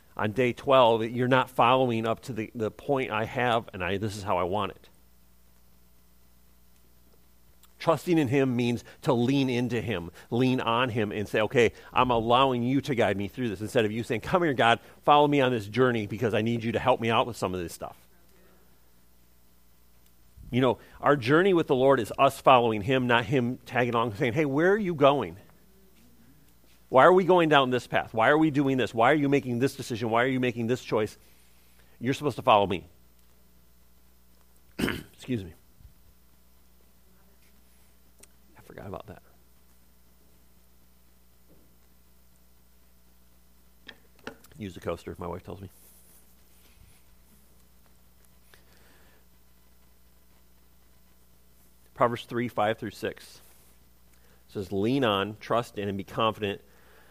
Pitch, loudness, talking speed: 95 Hz, -26 LUFS, 155 wpm